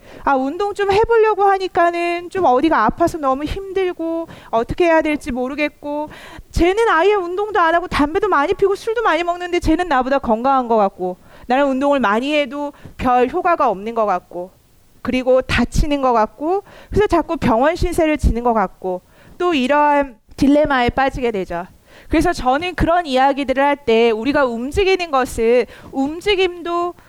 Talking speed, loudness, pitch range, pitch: 335 characters per minute, -17 LUFS, 250-350 Hz, 290 Hz